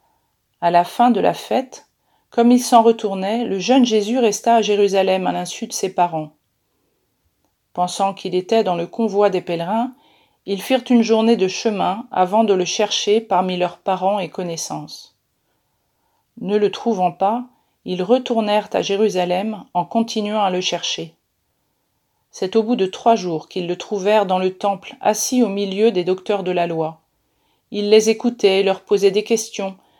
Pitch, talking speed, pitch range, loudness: 200 Hz, 170 wpm, 180-225 Hz, -18 LUFS